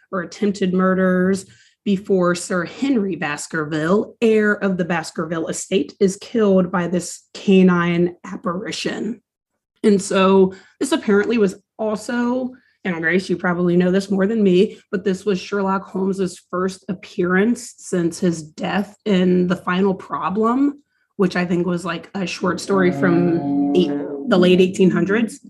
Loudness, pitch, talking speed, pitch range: -19 LUFS, 190 Hz, 140 wpm, 180-205 Hz